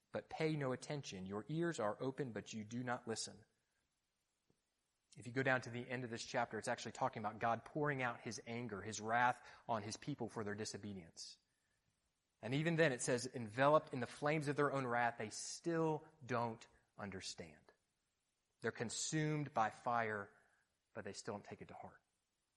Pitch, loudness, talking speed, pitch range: 120 Hz, -42 LUFS, 185 wpm, 110-135 Hz